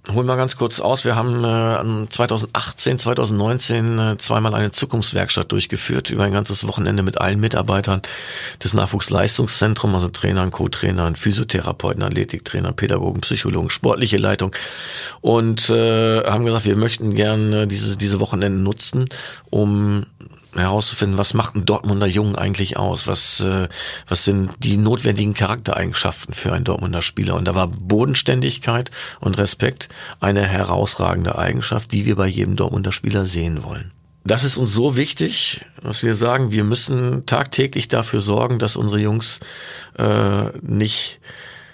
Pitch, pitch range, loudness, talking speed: 105 Hz, 100-115 Hz, -19 LUFS, 140 wpm